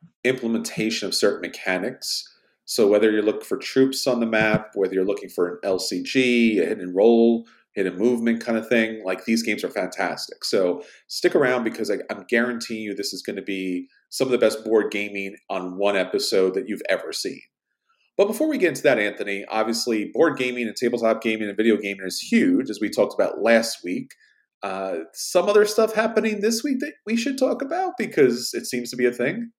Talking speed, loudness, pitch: 205 wpm, -22 LUFS, 115 Hz